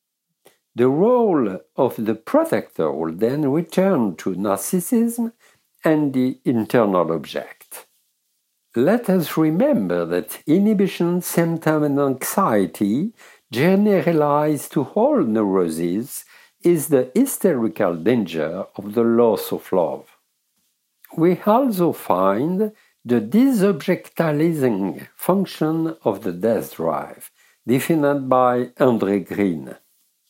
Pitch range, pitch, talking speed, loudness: 115-185 Hz, 155 Hz, 95 wpm, -20 LUFS